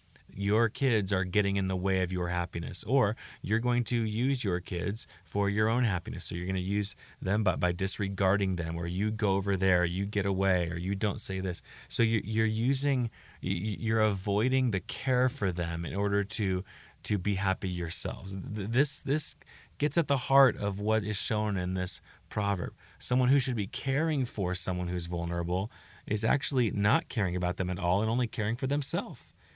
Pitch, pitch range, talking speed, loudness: 100 Hz, 95-115 Hz, 195 wpm, -30 LUFS